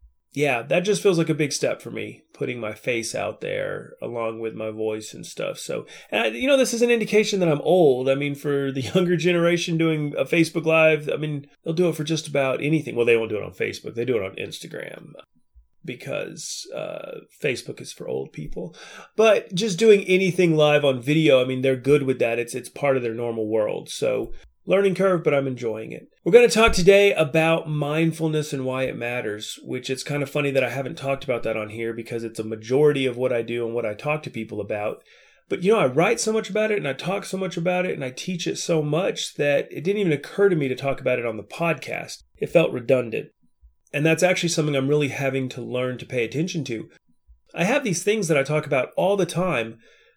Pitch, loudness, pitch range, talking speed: 150 Hz, -22 LUFS, 125-175 Hz, 240 wpm